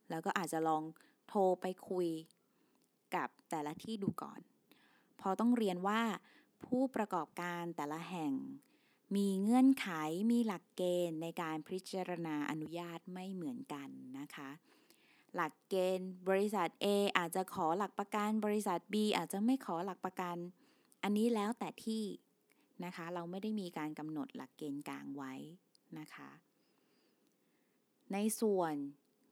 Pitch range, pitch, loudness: 165-215 Hz, 185 Hz, -38 LUFS